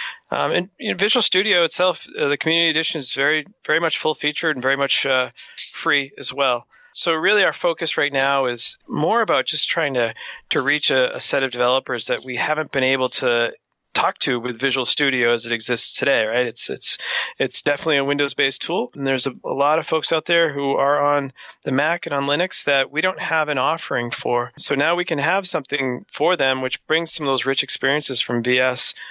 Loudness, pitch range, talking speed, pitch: -20 LUFS, 130-160 Hz, 220 wpm, 145 Hz